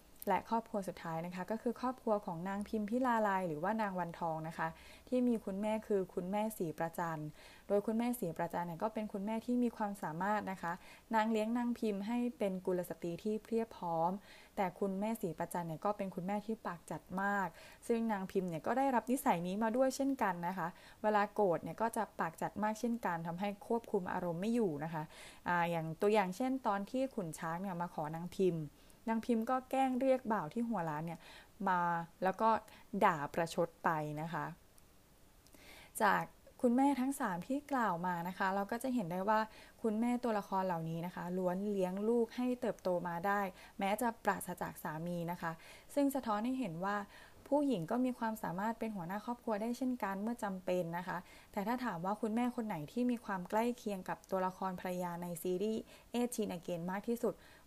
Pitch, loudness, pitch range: 205 Hz, -38 LUFS, 175-230 Hz